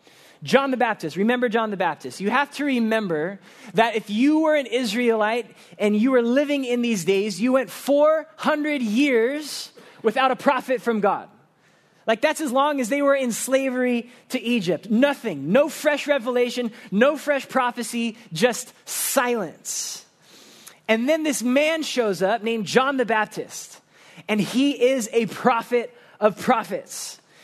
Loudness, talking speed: -22 LUFS, 155 wpm